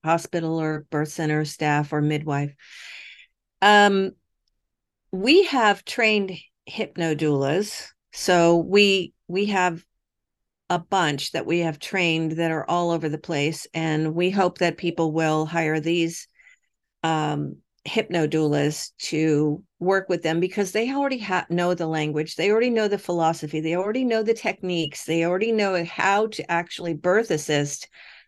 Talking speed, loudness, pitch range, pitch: 145 wpm, -23 LUFS, 155-195 Hz, 170 Hz